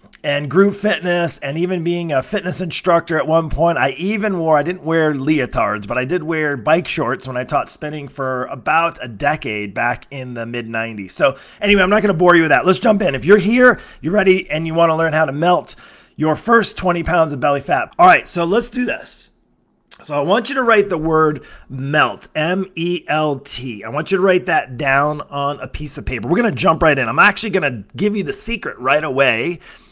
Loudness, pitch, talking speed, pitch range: -16 LUFS, 165 Hz, 230 wpm, 145-185 Hz